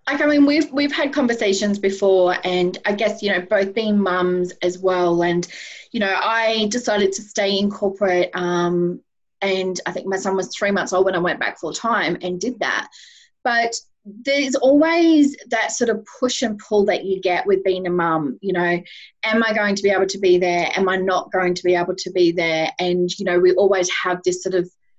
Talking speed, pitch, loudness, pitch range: 220 wpm, 195 Hz, -19 LUFS, 180-225 Hz